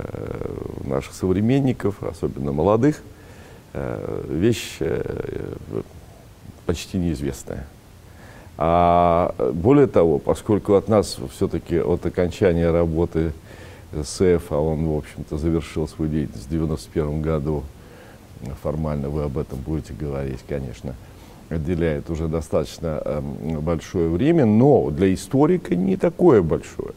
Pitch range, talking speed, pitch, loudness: 75-105 Hz, 100 wpm, 85 Hz, -22 LUFS